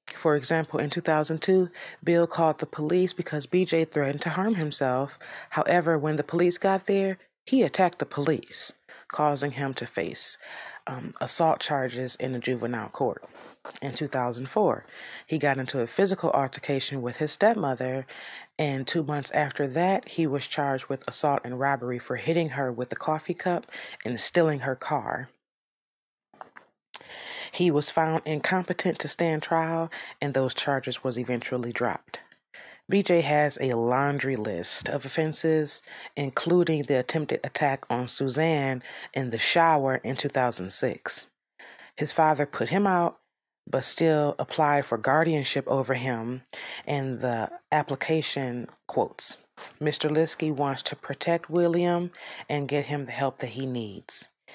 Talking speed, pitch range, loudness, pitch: 145 wpm, 135-165 Hz, -27 LUFS, 150 Hz